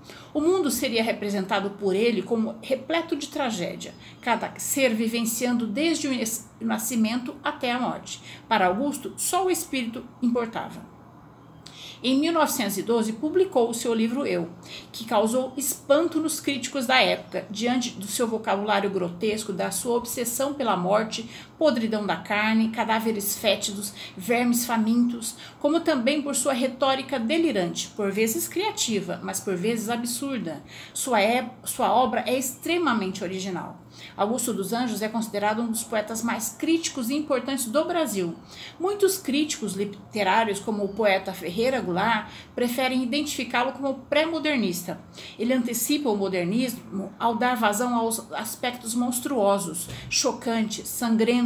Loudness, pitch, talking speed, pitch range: -25 LUFS, 235 Hz, 135 wpm, 210-270 Hz